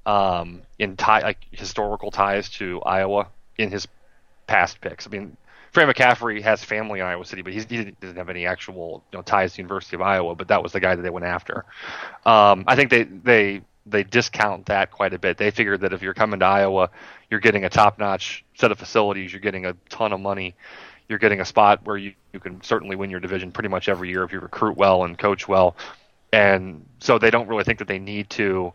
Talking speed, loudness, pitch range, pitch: 230 wpm, -21 LUFS, 95-105 Hz, 100 Hz